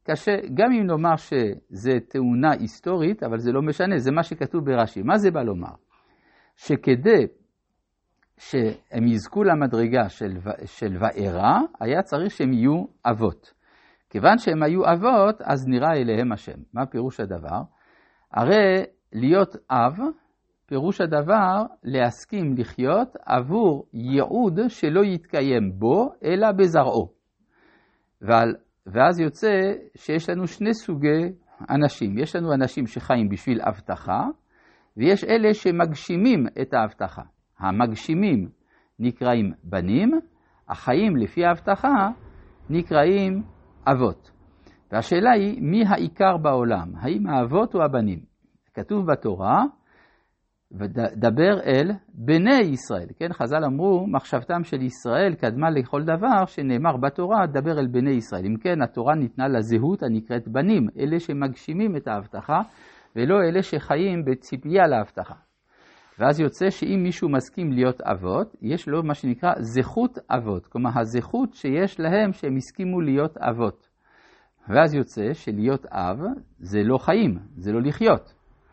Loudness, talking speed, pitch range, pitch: -22 LUFS, 120 wpm, 120-190 Hz, 150 Hz